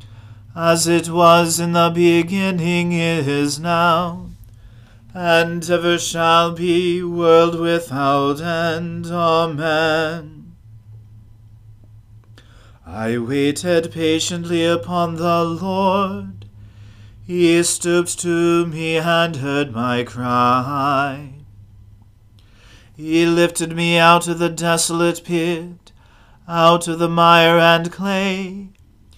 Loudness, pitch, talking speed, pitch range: -17 LUFS, 165 Hz, 90 wpm, 110-170 Hz